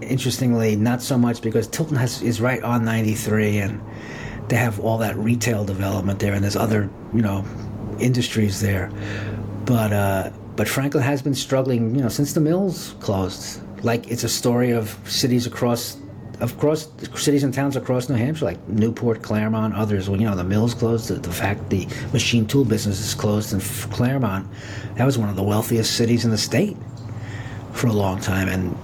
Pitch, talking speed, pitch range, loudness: 115 Hz, 185 wpm, 105-120 Hz, -22 LUFS